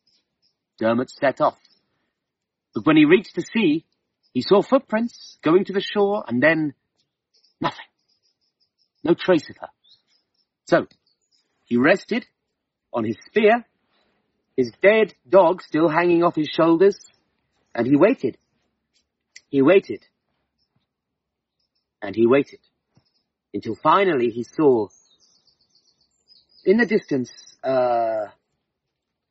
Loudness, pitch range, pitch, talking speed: -20 LUFS, 140-215 Hz, 190 Hz, 110 wpm